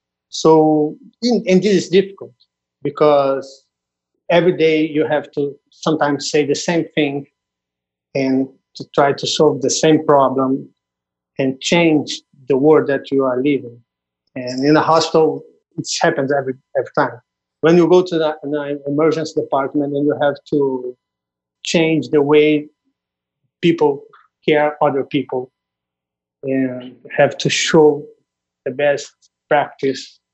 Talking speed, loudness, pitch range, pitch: 135 wpm, -16 LUFS, 130-160 Hz, 145 Hz